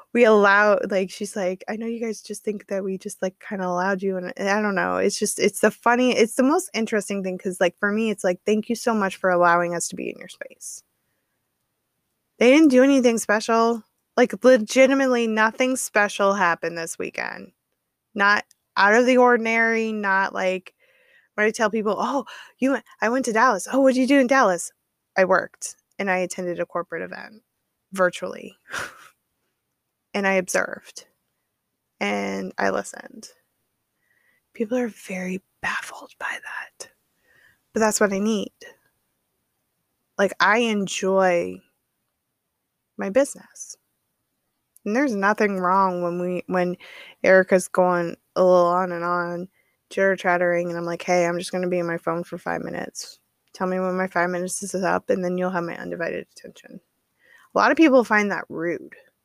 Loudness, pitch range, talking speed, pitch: -21 LUFS, 180-230 Hz, 175 wpm, 200 Hz